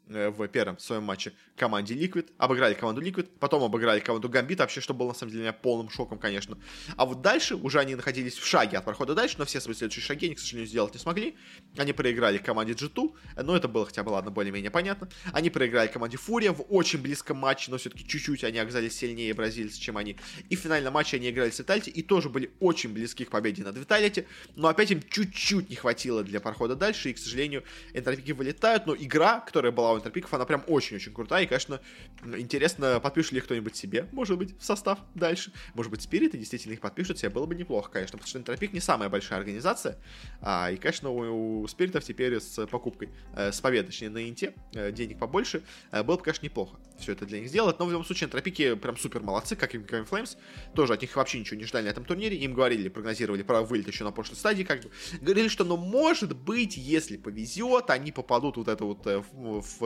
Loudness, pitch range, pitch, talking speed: -29 LUFS, 110-170 Hz, 130 Hz, 220 wpm